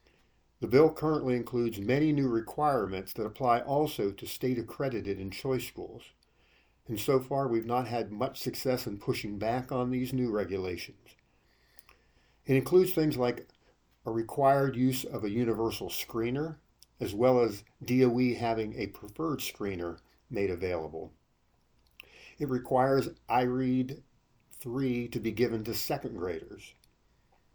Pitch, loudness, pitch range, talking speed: 120 Hz, -31 LUFS, 105-130 Hz, 135 wpm